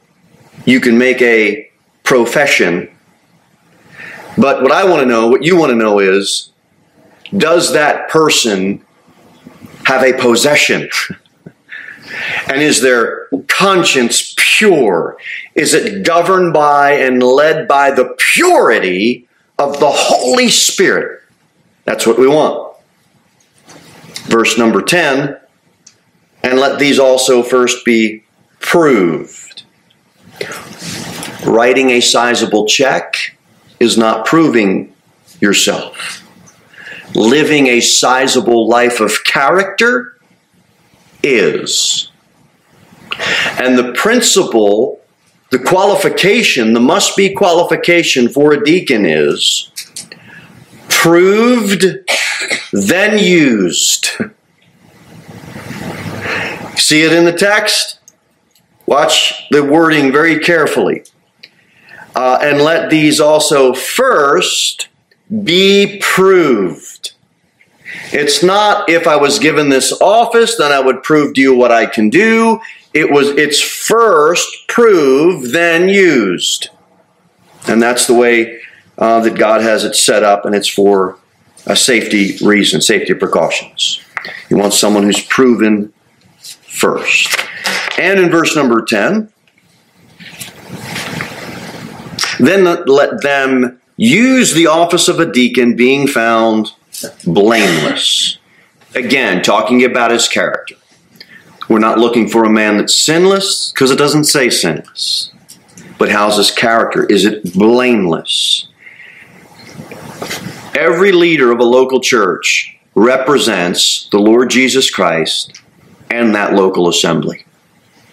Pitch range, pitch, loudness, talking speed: 115-185 Hz, 140 Hz, -10 LUFS, 105 wpm